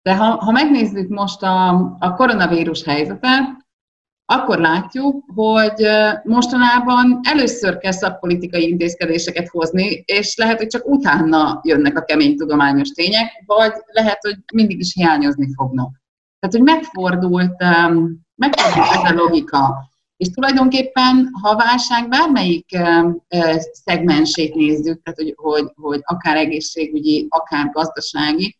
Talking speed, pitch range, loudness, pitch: 120 wpm, 160-225 Hz, -15 LUFS, 180 Hz